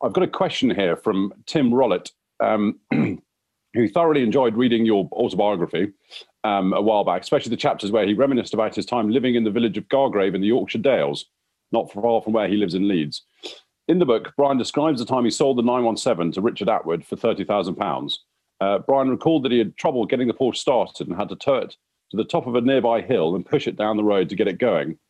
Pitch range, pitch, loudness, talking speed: 110-135 Hz, 120 Hz, -21 LUFS, 235 wpm